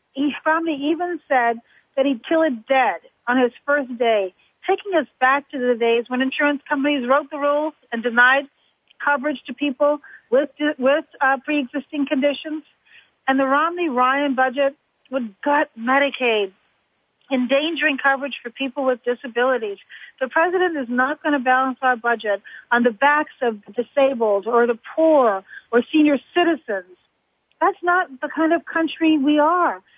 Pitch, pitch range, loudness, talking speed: 275 Hz, 250-300 Hz, -20 LUFS, 150 wpm